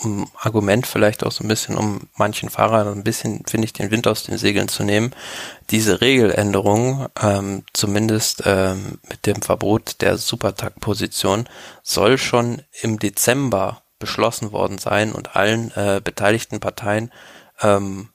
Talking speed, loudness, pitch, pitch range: 145 wpm, -19 LUFS, 105 Hz, 100-115 Hz